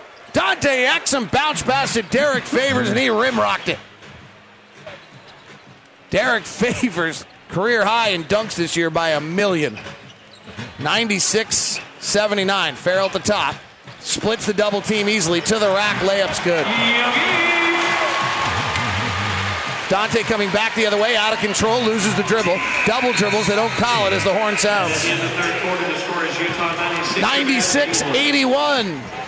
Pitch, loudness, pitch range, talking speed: 210 Hz, -18 LUFS, 180-230 Hz, 125 wpm